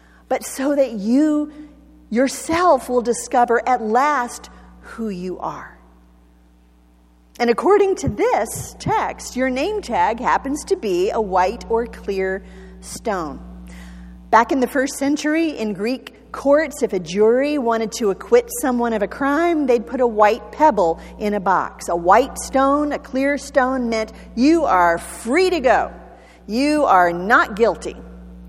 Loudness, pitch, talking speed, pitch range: -19 LUFS, 235 Hz, 145 wpm, 190-280 Hz